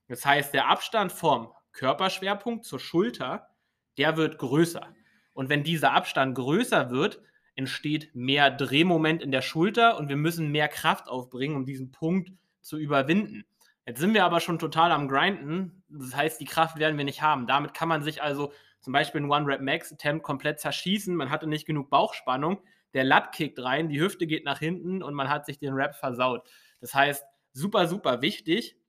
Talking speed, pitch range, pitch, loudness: 180 wpm, 140-170 Hz, 150 Hz, -26 LUFS